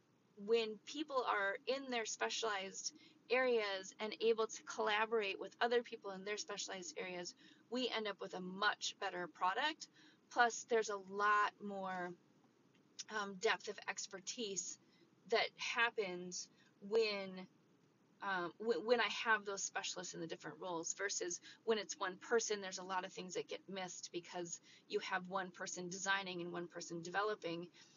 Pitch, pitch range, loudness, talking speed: 200 Hz, 185-230 Hz, -41 LUFS, 155 wpm